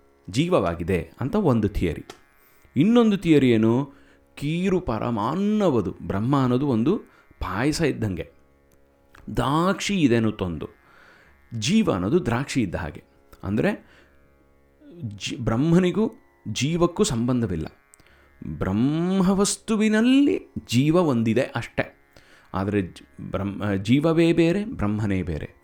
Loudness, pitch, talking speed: -23 LUFS, 115 Hz, 85 wpm